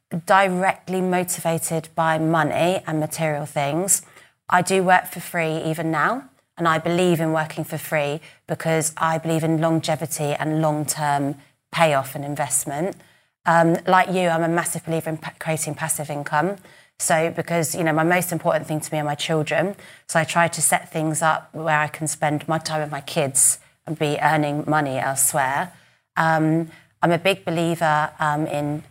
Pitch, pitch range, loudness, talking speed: 160 Hz, 150-170 Hz, -21 LUFS, 175 wpm